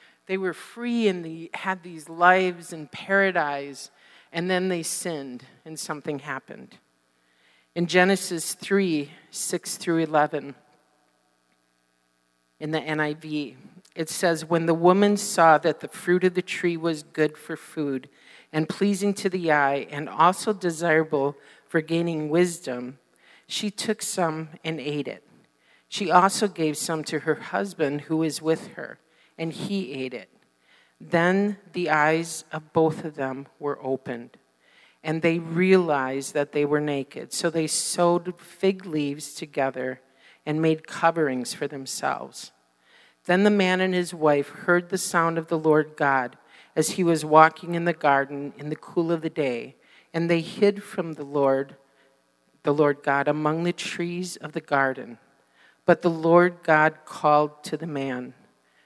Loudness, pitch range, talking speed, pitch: -24 LUFS, 145-175 Hz, 155 wpm, 160 Hz